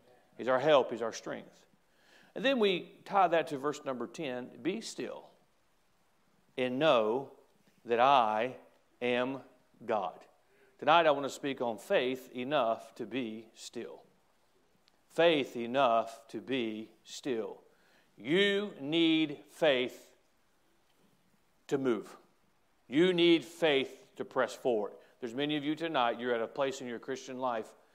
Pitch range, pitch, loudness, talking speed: 125-160 Hz, 130 Hz, -32 LUFS, 135 wpm